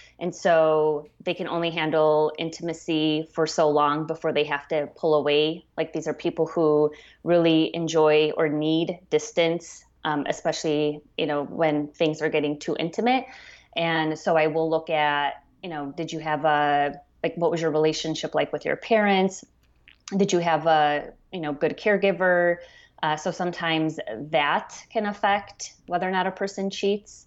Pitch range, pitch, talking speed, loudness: 155-175 Hz, 160 Hz, 170 wpm, -24 LUFS